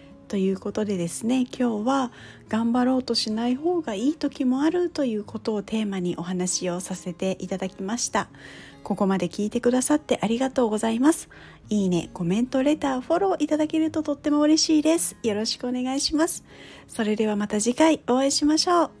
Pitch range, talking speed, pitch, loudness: 210-295 Hz, 405 characters per minute, 245 Hz, -24 LUFS